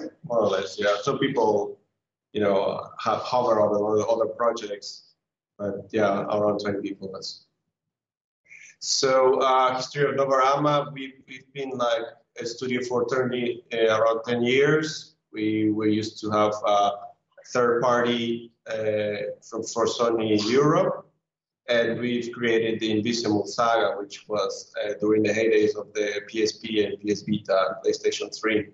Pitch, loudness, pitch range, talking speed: 120 Hz, -24 LUFS, 105-135 Hz, 155 wpm